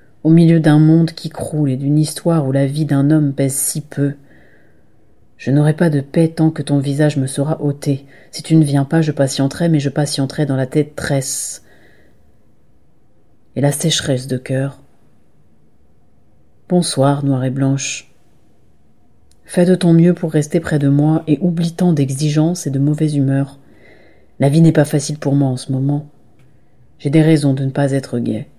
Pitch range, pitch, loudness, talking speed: 135-155 Hz, 140 Hz, -15 LUFS, 185 wpm